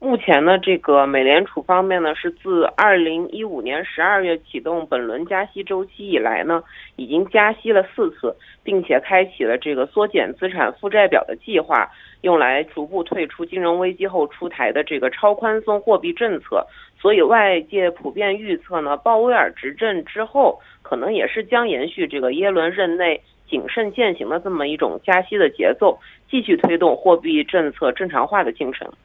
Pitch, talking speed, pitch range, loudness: 185 Hz, 280 characters per minute, 165-215 Hz, -19 LUFS